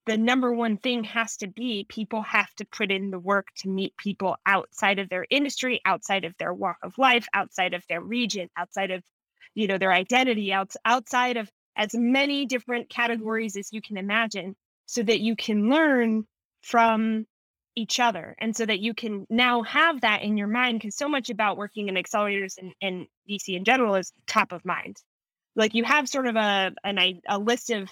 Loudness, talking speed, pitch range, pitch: -25 LUFS, 200 wpm, 195-235 Hz, 220 Hz